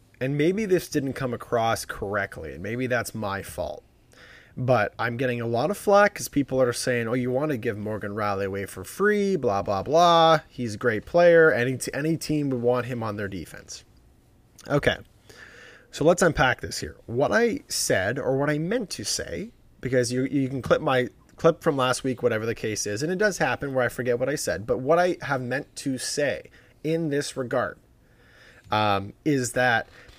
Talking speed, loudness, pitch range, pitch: 200 wpm, -24 LUFS, 115-150 Hz, 125 Hz